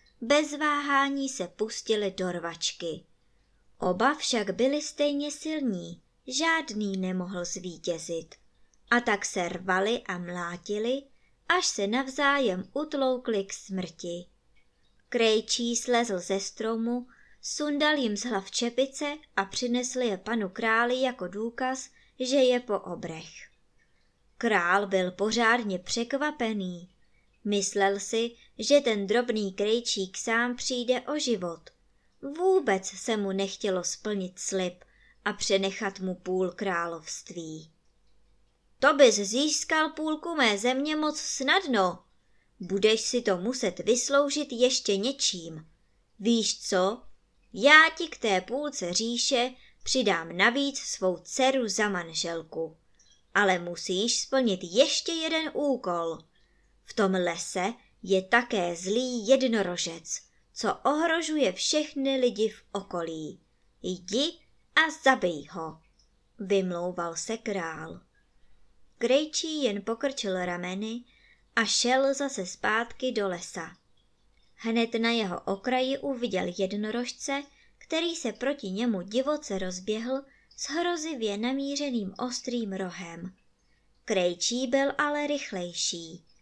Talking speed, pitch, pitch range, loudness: 110 wpm, 225 Hz, 185-265 Hz, -28 LUFS